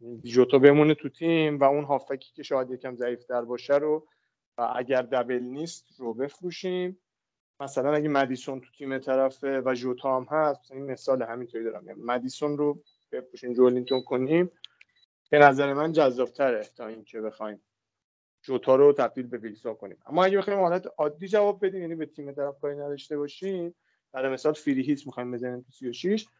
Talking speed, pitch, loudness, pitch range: 160 wpm, 135 Hz, -26 LUFS, 125-155 Hz